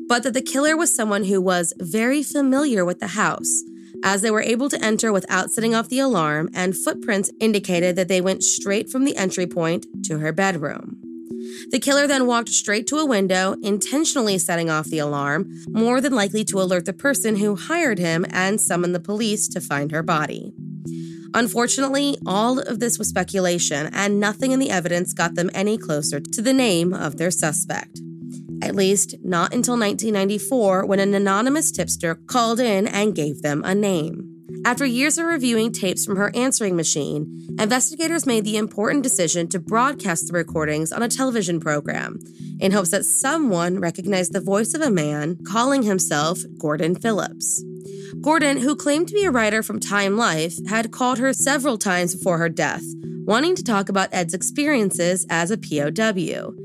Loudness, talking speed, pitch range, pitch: -20 LUFS, 180 wpm, 175-235 Hz, 195 Hz